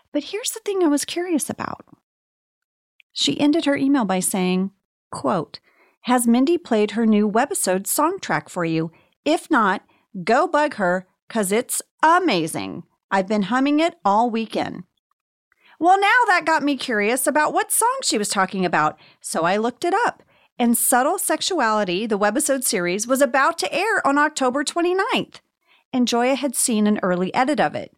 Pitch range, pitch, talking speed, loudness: 210-320 Hz, 255 Hz, 165 wpm, -20 LUFS